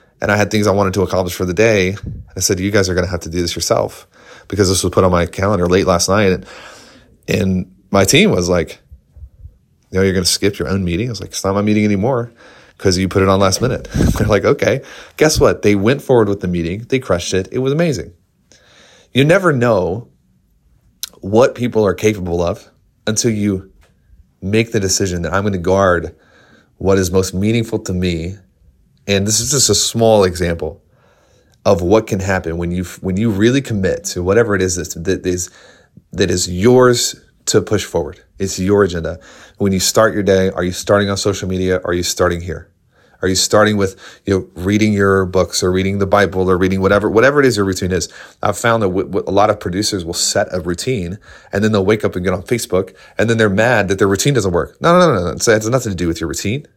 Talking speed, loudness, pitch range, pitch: 230 wpm, -15 LUFS, 90-105 Hz, 95 Hz